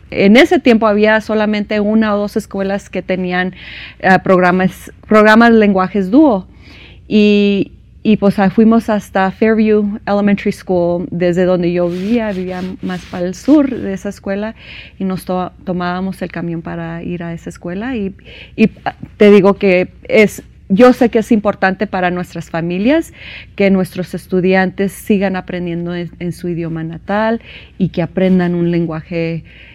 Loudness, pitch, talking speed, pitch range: -14 LUFS, 190 Hz, 155 wpm, 180-215 Hz